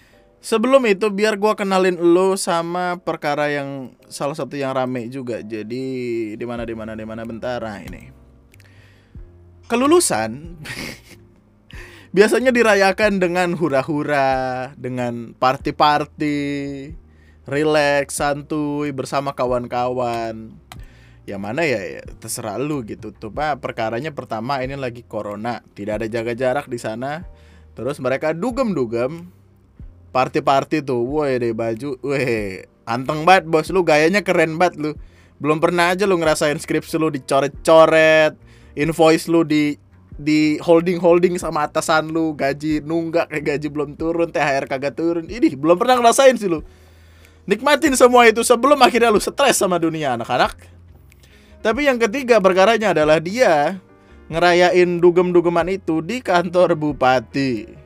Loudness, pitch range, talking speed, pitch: -18 LUFS, 120-170 Hz, 125 wpm, 145 Hz